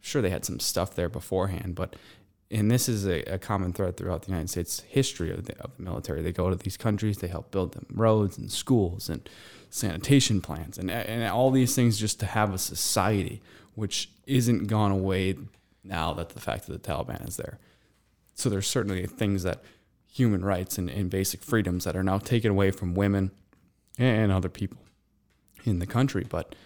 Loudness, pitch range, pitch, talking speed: -28 LUFS, 90-110 Hz, 95 Hz, 200 wpm